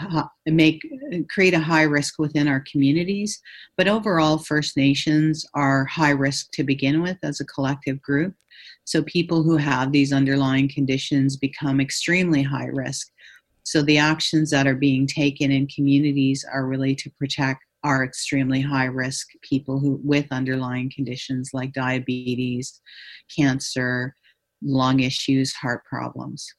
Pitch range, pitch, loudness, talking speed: 135-155 Hz, 140 Hz, -22 LUFS, 140 wpm